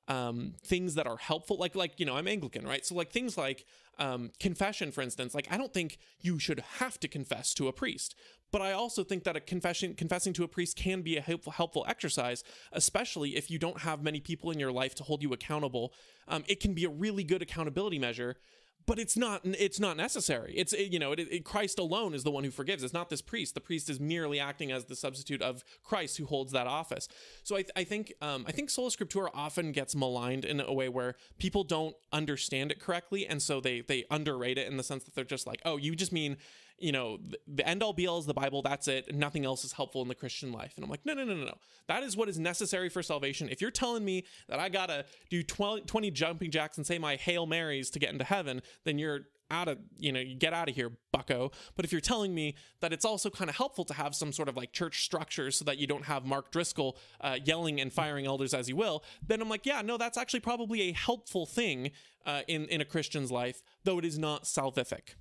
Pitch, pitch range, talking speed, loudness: 160 Hz, 140-190 Hz, 250 wpm, -34 LUFS